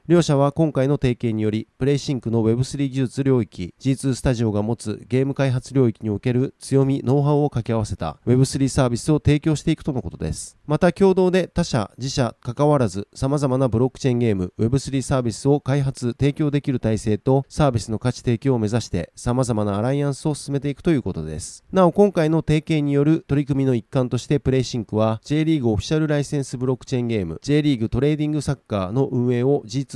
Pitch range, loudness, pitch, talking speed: 115-145 Hz, -21 LUFS, 135 Hz, 465 characters per minute